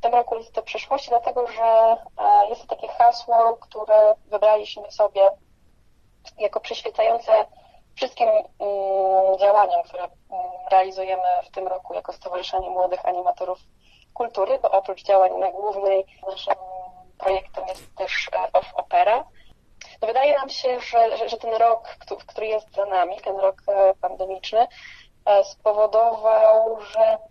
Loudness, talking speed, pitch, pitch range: -21 LUFS, 120 wpm, 220 Hz, 195-260 Hz